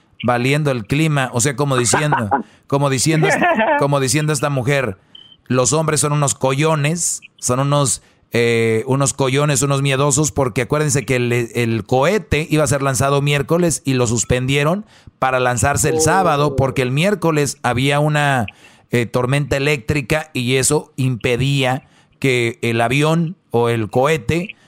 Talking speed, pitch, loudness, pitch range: 145 wpm, 140 Hz, -17 LUFS, 125-150 Hz